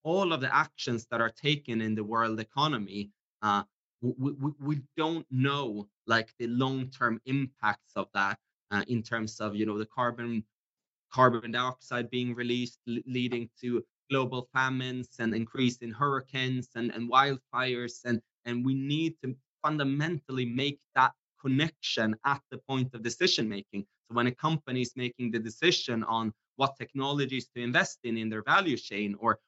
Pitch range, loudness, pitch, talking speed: 115-135 Hz, -31 LUFS, 125 Hz, 165 wpm